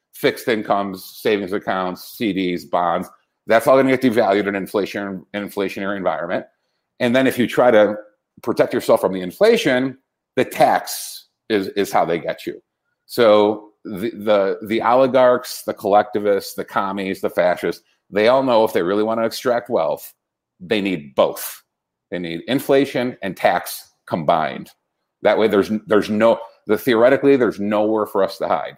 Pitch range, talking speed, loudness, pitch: 95-125 Hz, 165 wpm, -19 LUFS, 105 Hz